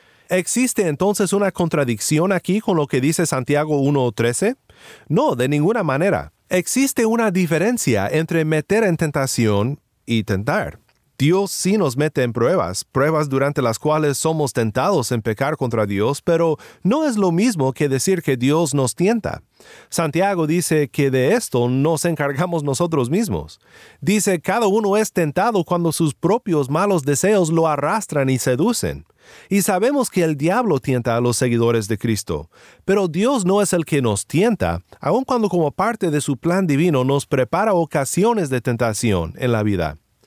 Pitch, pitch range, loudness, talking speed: 155 Hz, 130-190 Hz, -19 LUFS, 160 wpm